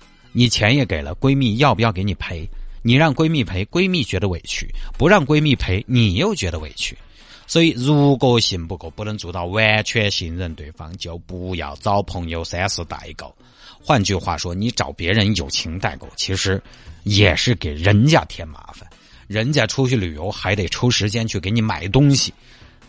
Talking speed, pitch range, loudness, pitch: 265 characters per minute, 90-120 Hz, -18 LUFS, 100 Hz